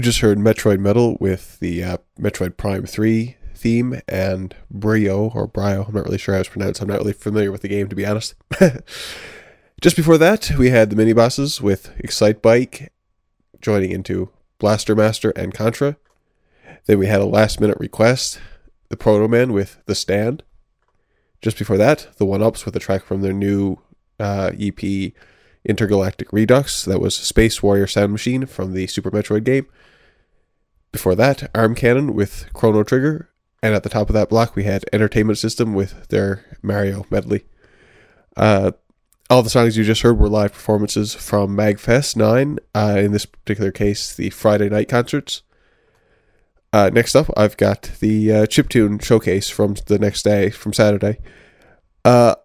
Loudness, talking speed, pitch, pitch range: -18 LUFS, 170 wpm, 105 Hz, 100-115 Hz